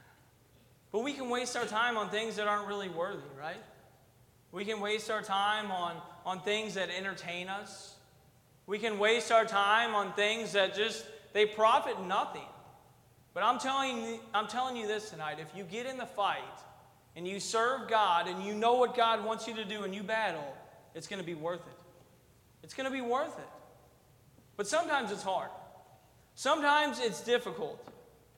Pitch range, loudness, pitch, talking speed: 175-225 Hz, -32 LUFS, 205 Hz, 180 wpm